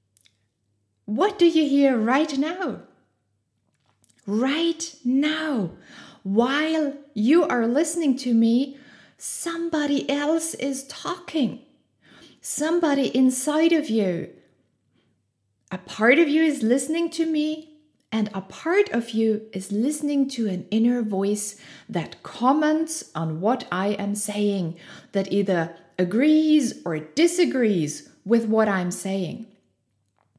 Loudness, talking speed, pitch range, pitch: -23 LUFS, 115 wpm, 190-300 Hz, 235 Hz